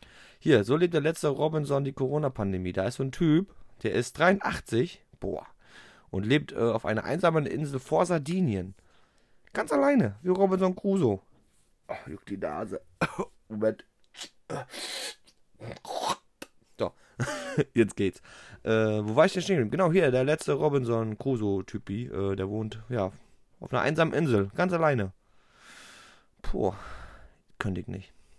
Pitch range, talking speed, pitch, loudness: 105-160 Hz, 135 wpm, 130 Hz, -28 LUFS